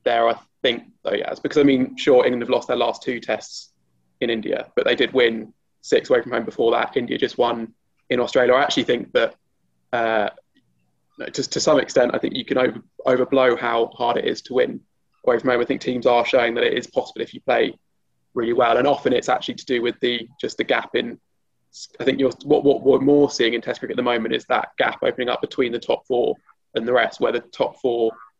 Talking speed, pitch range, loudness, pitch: 240 wpm, 115-145 Hz, -21 LUFS, 120 Hz